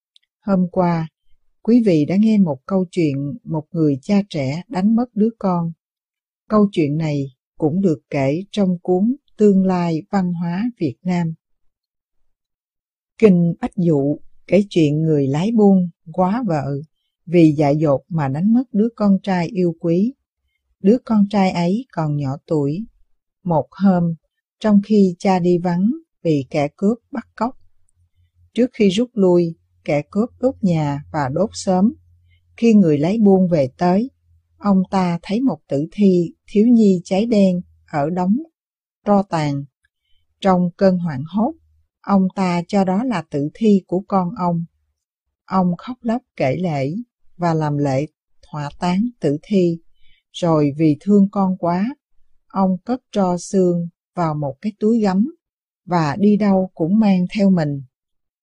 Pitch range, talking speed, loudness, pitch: 150-205 Hz, 155 wpm, -18 LUFS, 180 Hz